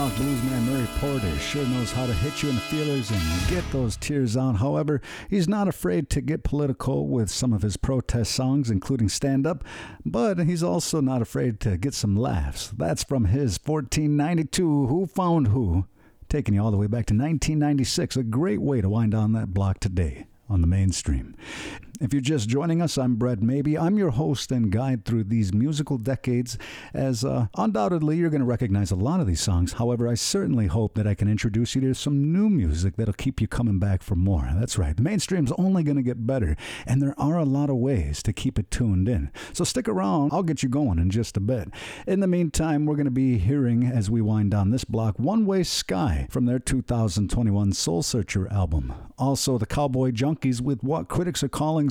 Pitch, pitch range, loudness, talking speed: 125 Hz, 105-145 Hz, -24 LUFS, 210 wpm